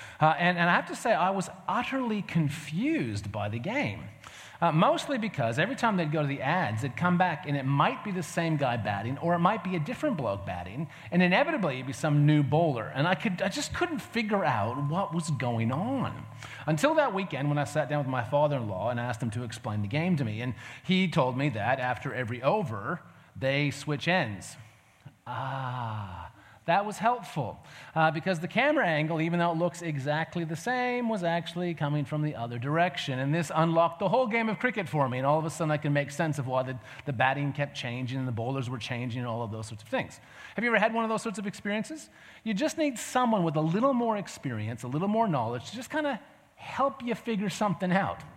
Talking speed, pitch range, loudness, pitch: 230 wpm, 130-195 Hz, -29 LUFS, 155 Hz